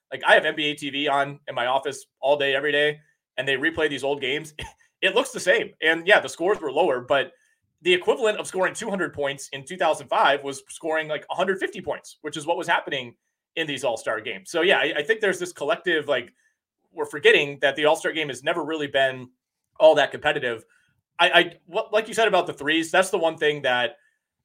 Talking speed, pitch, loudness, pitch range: 215 wpm, 160 Hz, -23 LUFS, 145-210 Hz